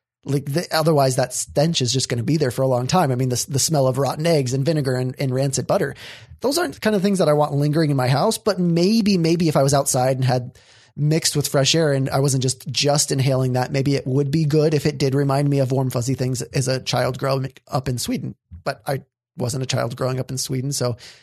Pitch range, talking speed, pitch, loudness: 130-150 Hz, 265 wpm, 135 Hz, -20 LUFS